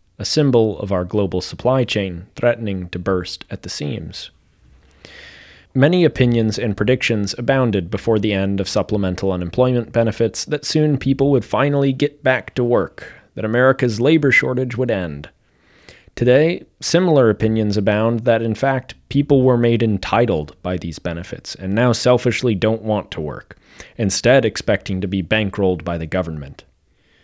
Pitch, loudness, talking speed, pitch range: 110 Hz, -18 LUFS, 150 wpm, 95-125 Hz